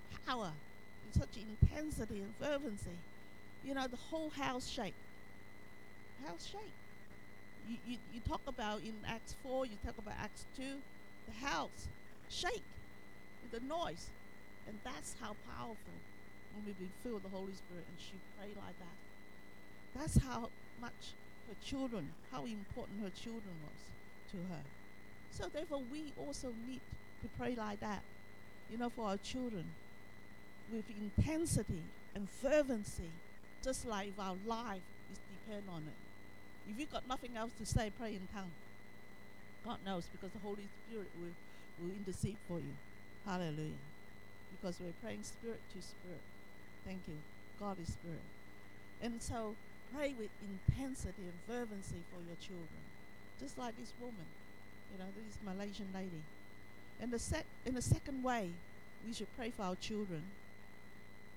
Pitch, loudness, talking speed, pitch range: 205 Hz, -45 LUFS, 150 wpm, 170-240 Hz